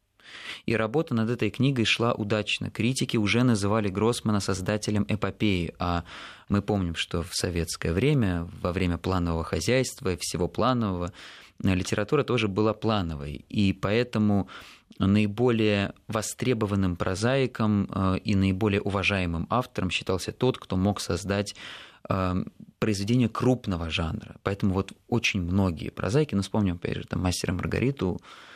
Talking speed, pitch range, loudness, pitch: 125 wpm, 95-115 Hz, -27 LUFS, 105 Hz